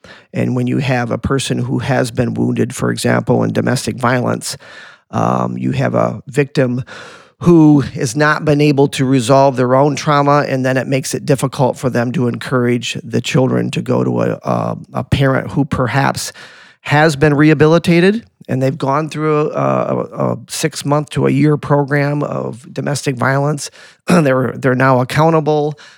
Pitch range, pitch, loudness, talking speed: 125-150 Hz, 135 Hz, -15 LUFS, 165 wpm